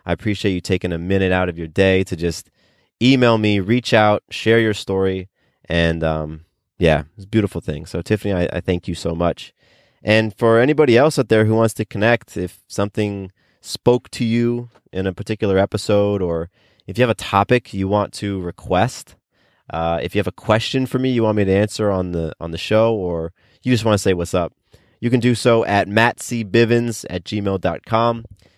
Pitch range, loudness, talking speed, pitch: 90-115 Hz, -19 LUFS, 205 wpm, 100 Hz